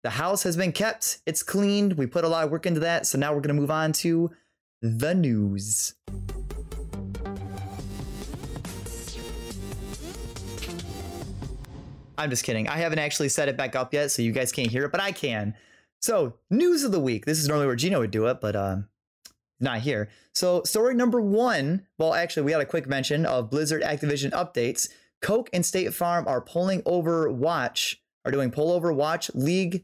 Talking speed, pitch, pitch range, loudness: 185 wpm, 145 Hz, 110-170 Hz, -26 LUFS